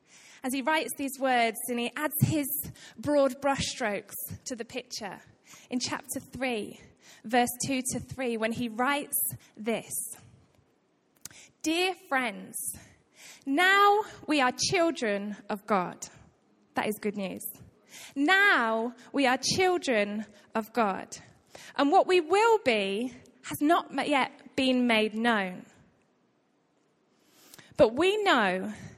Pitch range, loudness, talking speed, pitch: 225-295 Hz, -28 LUFS, 120 wpm, 255 Hz